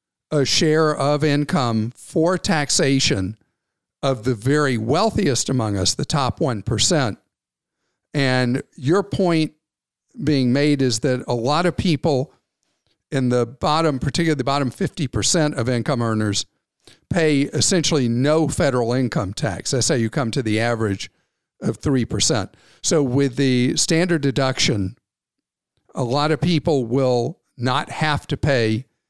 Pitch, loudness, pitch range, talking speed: 140 Hz, -20 LUFS, 125-155 Hz, 135 wpm